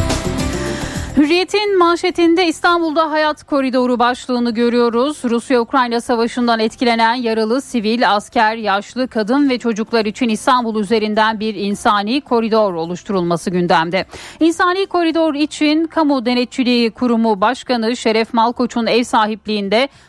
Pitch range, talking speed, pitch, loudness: 220-280 Hz, 110 wpm, 240 Hz, -16 LUFS